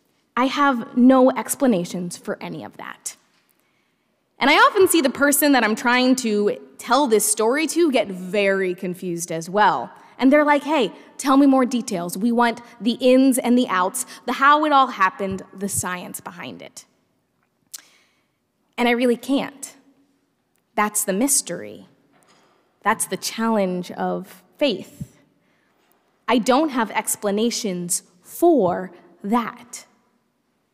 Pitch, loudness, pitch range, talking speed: 235 Hz, -19 LUFS, 195-265 Hz, 135 wpm